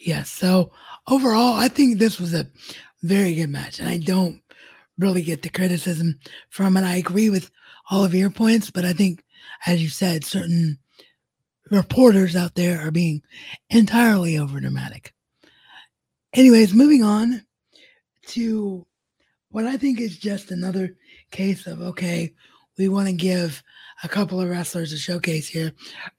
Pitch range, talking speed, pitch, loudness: 170-210 Hz, 150 wpm, 185 Hz, -20 LUFS